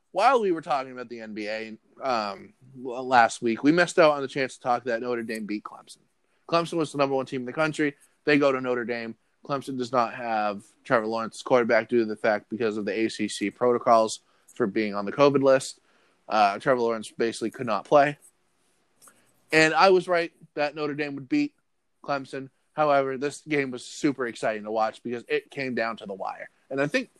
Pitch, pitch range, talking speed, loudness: 130 Hz, 115-145 Hz, 205 wpm, -25 LUFS